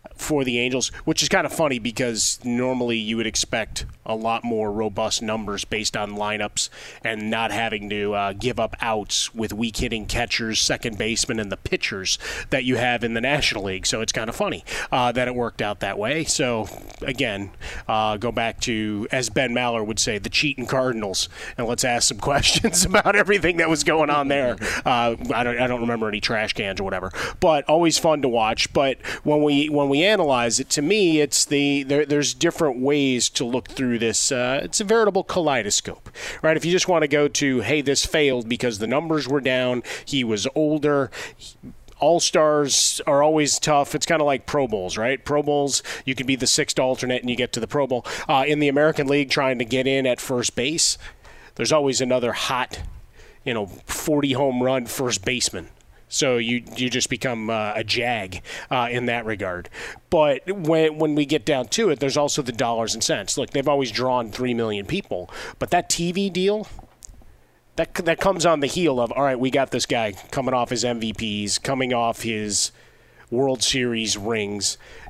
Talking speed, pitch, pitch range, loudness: 200 wpm, 125 Hz, 115-145 Hz, -22 LUFS